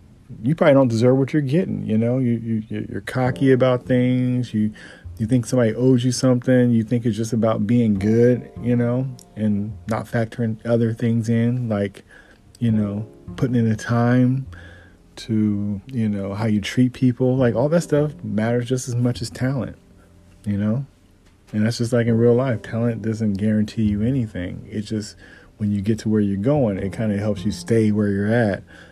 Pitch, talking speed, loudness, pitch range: 115 Hz, 195 wpm, -21 LUFS, 105-125 Hz